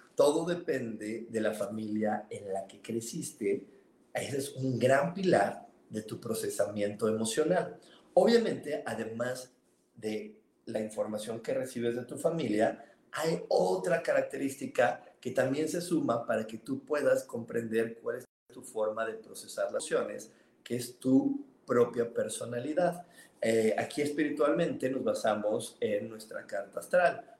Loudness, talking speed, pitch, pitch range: -32 LUFS, 135 wpm, 125 Hz, 110-170 Hz